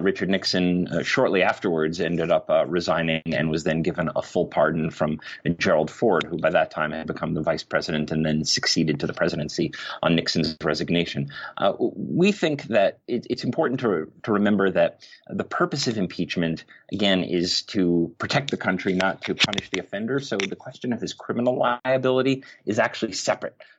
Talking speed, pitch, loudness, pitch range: 185 wpm, 90 Hz, -24 LUFS, 80-105 Hz